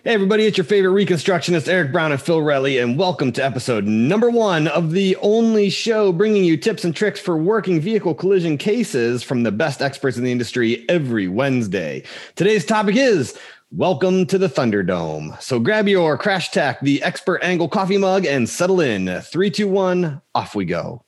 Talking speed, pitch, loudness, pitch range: 180 wpm, 175 Hz, -18 LUFS, 140-195 Hz